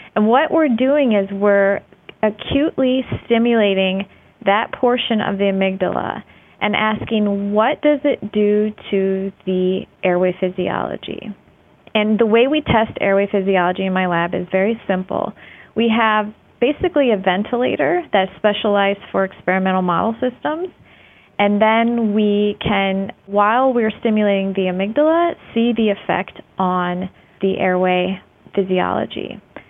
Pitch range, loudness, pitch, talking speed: 190-230 Hz, -18 LUFS, 205 Hz, 125 wpm